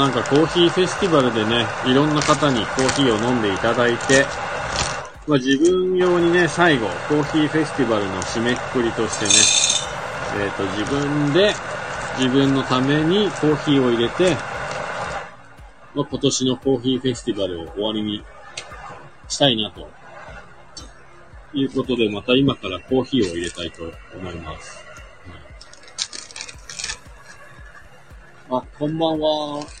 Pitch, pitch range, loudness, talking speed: 130 Hz, 110-150 Hz, -19 LUFS, 290 characters per minute